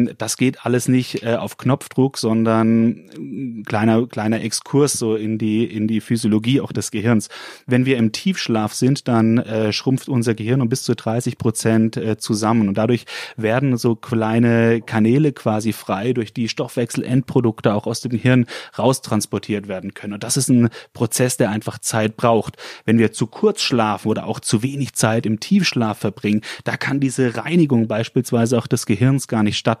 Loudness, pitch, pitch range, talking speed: -19 LUFS, 115 Hz, 110-130 Hz, 170 wpm